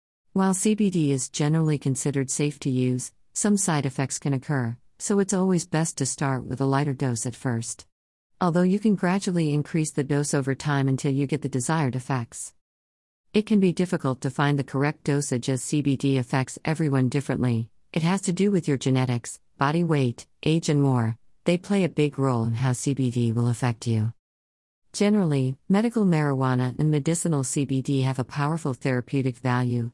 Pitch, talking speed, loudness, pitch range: 140 Hz, 175 wpm, -25 LUFS, 125-160 Hz